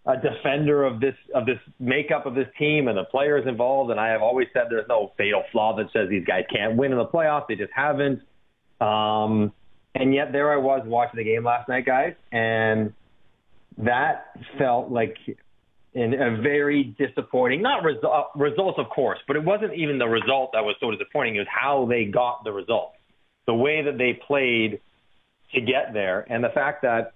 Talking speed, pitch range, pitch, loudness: 200 wpm, 115-140 Hz, 125 Hz, -23 LUFS